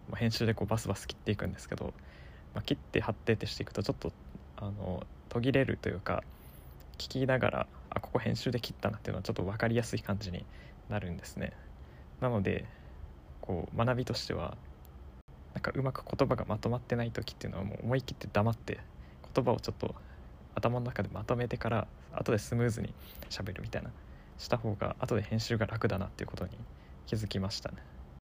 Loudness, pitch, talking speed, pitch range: -35 LUFS, 100 Hz, 405 characters per minute, 70-115 Hz